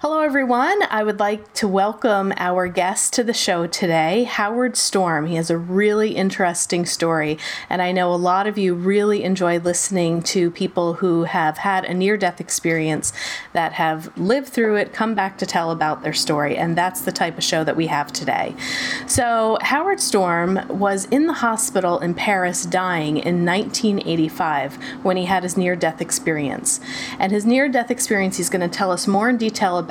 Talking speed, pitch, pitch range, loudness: 185 wpm, 190 Hz, 175-215 Hz, -20 LUFS